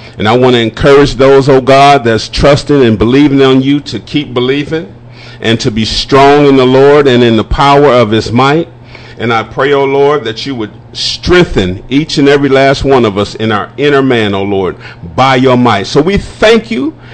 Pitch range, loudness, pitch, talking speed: 115-140 Hz, -8 LUFS, 130 Hz, 220 wpm